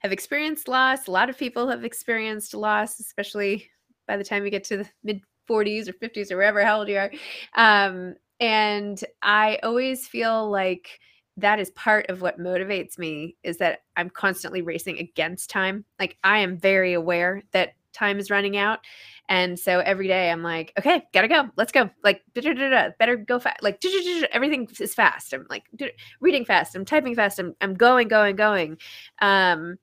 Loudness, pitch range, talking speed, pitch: -22 LUFS, 190-230 Hz, 175 wpm, 205 Hz